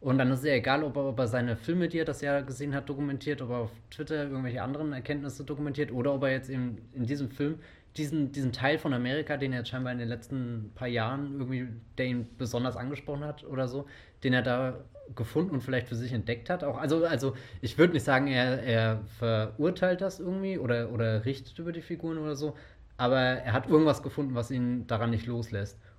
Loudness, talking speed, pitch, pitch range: -31 LUFS, 220 wpm, 130 Hz, 120-145 Hz